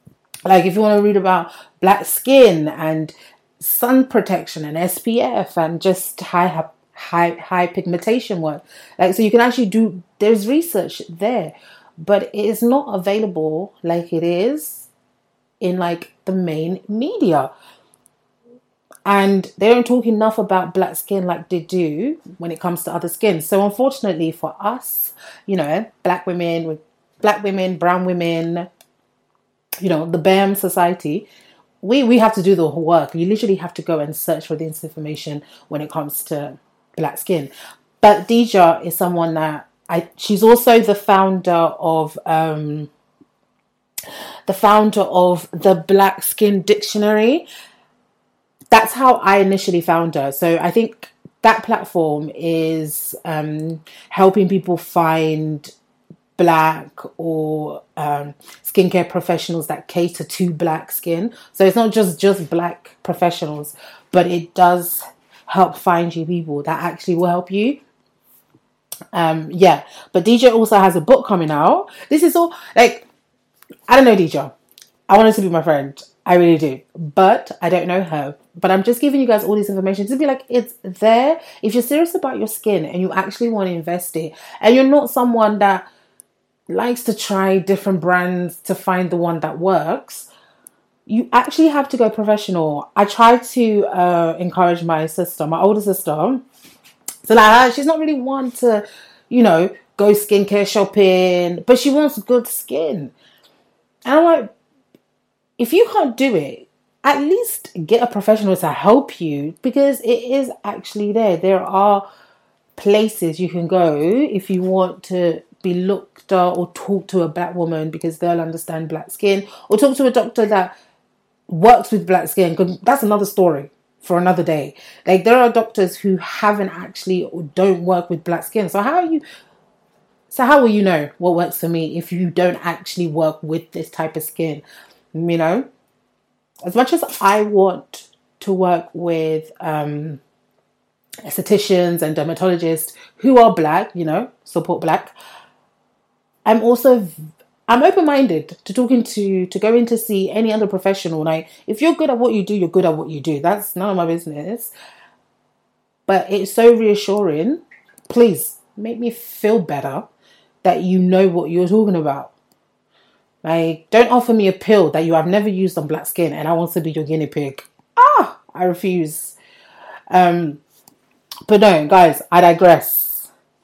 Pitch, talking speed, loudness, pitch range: 185 Hz, 165 wpm, -16 LUFS, 170-220 Hz